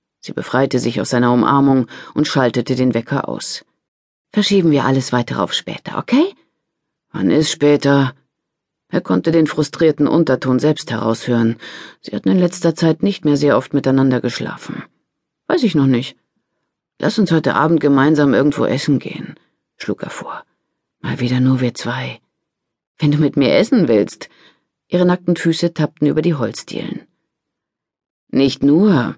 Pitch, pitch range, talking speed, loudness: 140 Hz, 125-160 Hz, 150 wpm, -16 LUFS